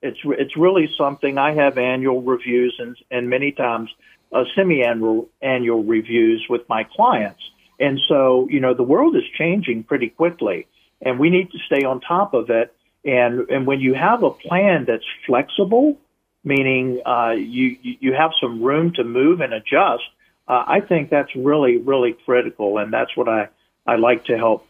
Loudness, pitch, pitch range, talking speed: -18 LUFS, 135 Hz, 125-165 Hz, 180 wpm